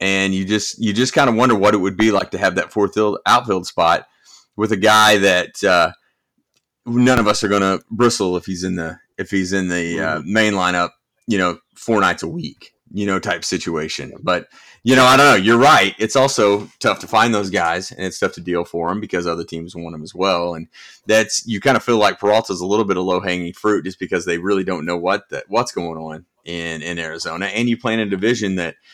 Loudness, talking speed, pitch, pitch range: -17 LUFS, 240 wpm, 95 Hz, 85-110 Hz